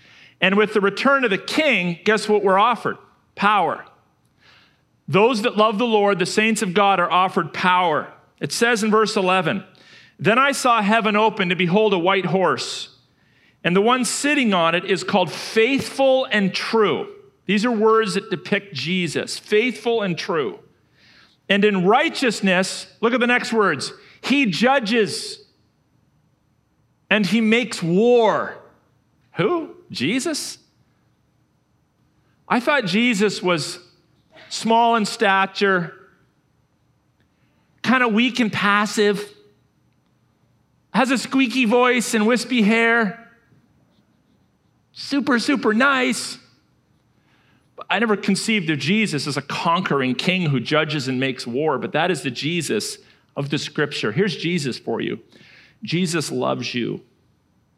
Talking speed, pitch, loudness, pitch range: 130 wpm, 210 Hz, -19 LUFS, 180-235 Hz